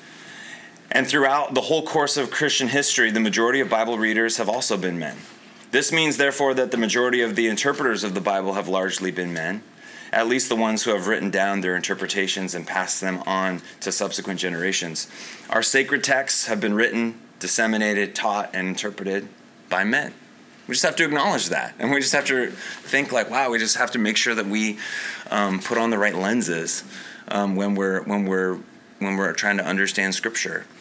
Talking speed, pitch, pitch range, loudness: 195 wpm, 105 Hz, 95-115 Hz, -22 LUFS